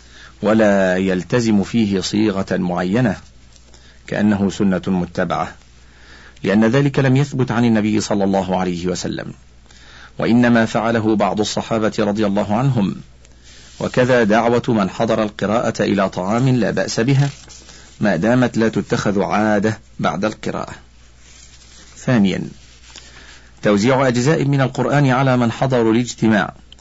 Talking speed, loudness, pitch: 115 wpm, -17 LUFS, 105 Hz